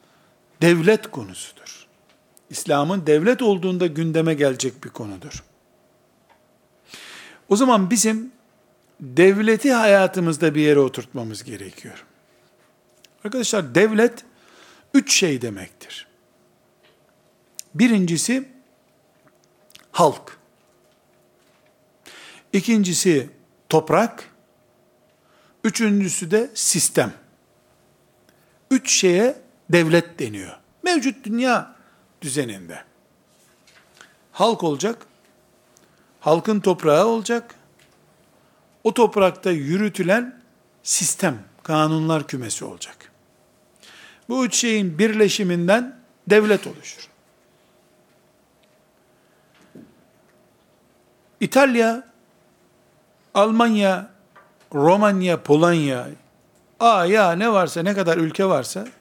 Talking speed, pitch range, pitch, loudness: 70 wpm, 160-225 Hz, 195 Hz, -19 LUFS